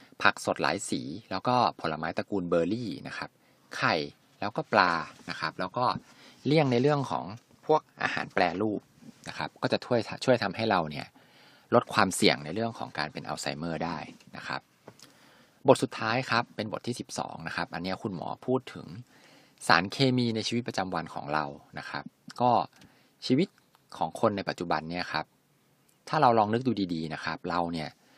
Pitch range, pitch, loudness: 85-120 Hz, 100 Hz, -29 LUFS